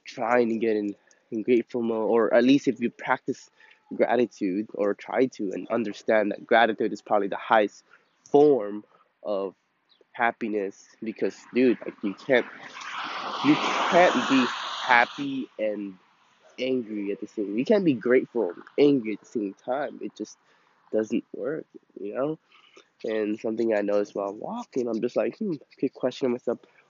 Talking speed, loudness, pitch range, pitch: 160 wpm, -26 LUFS, 105-135 Hz, 115 Hz